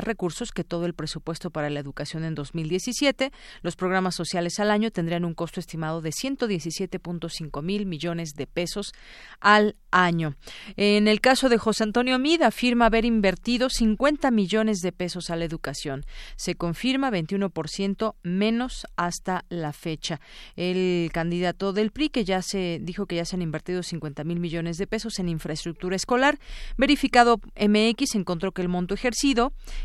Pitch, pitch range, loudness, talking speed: 185 Hz, 170-220 Hz, -25 LUFS, 160 wpm